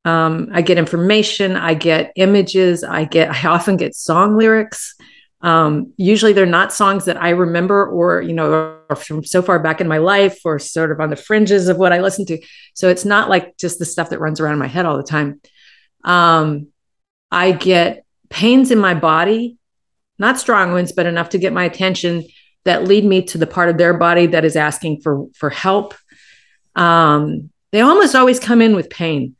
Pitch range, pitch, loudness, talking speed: 160-195 Hz, 175 Hz, -14 LUFS, 200 wpm